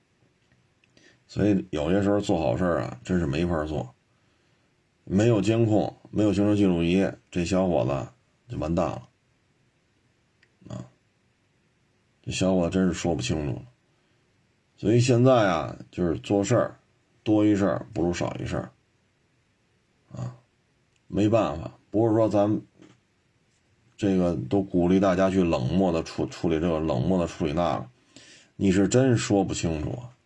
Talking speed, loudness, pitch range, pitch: 205 characters per minute, -25 LUFS, 85-105 Hz, 95 Hz